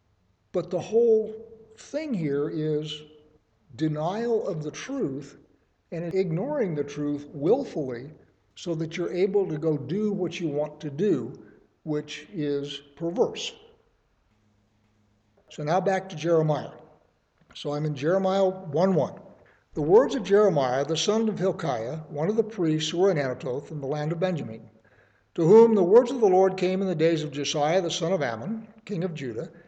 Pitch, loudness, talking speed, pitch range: 165 Hz, -26 LUFS, 170 wpm, 145-195 Hz